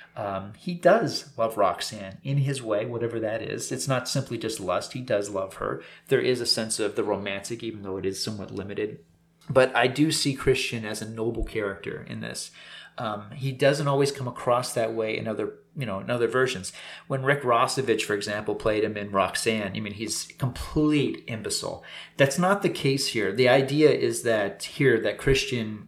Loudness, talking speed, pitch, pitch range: -26 LUFS, 195 wpm, 115 Hz, 105-135 Hz